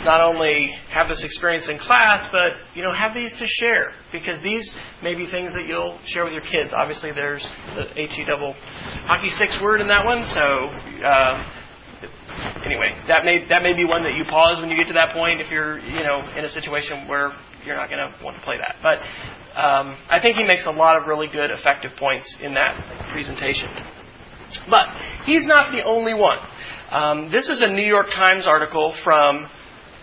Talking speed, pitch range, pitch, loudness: 205 wpm, 150-190 Hz, 165 Hz, -19 LUFS